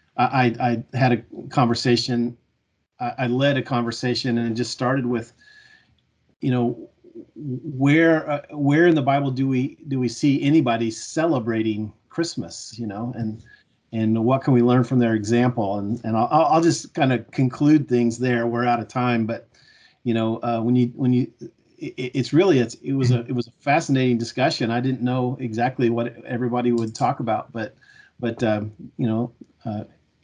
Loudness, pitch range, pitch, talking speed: -22 LUFS, 115-135 Hz, 125 Hz, 180 wpm